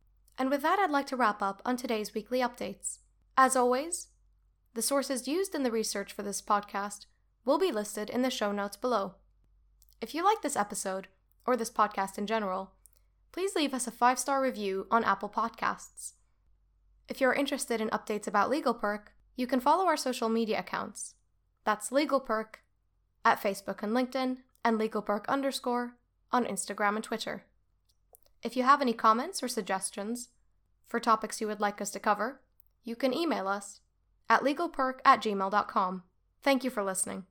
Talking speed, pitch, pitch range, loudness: 165 wpm, 230 Hz, 205-260 Hz, -30 LUFS